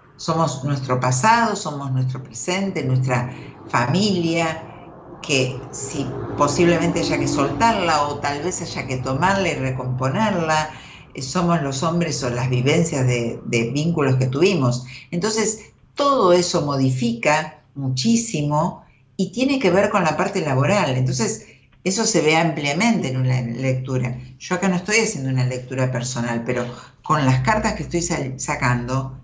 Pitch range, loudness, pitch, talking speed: 130-175 Hz, -20 LUFS, 145 Hz, 145 wpm